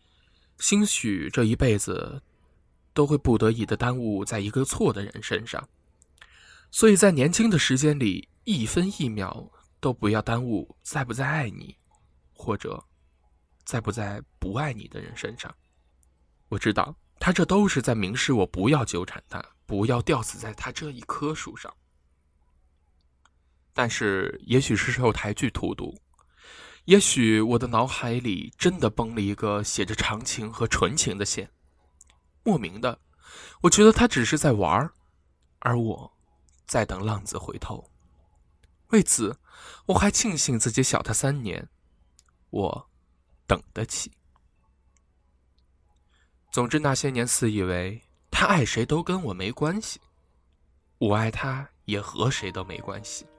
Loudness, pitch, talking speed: -25 LUFS, 105 Hz, 200 characters per minute